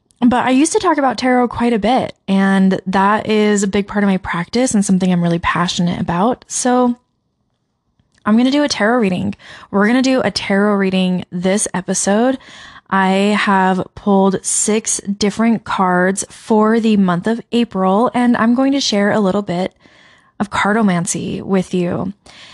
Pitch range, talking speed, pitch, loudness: 190-235 Hz, 175 wpm, 205 Hz, -15 LUFS